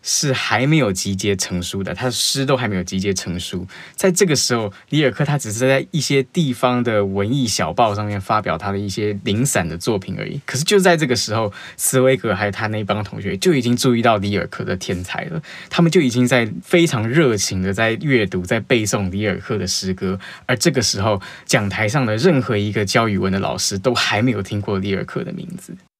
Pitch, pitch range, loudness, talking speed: 110 Hz, 100-135 Hz, -18 LUFS, 325 characters per minute